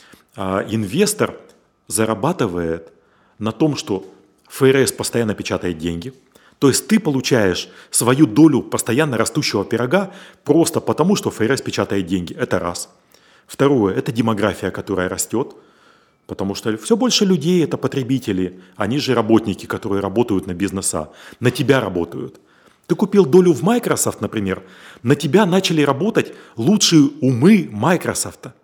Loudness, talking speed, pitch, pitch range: -18 LUFS, 130 wpm, 115 Hz, 100-155 Hz